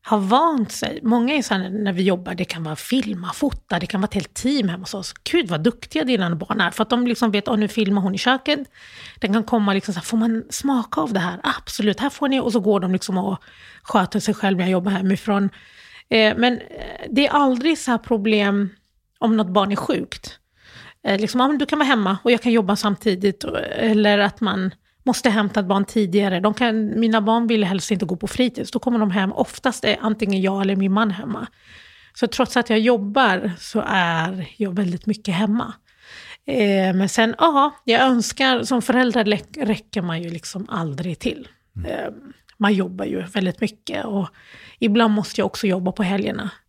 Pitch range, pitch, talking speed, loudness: 195-240 Hz, 215 Hz, 210 wpm, -20 LUFS